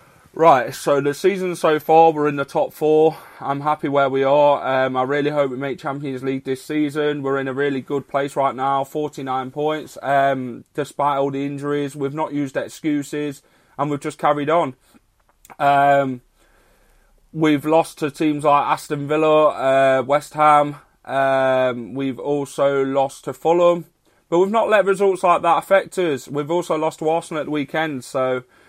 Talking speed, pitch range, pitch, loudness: 180 wpm, 135-155 Hz, 145 Hz, -19 LUFS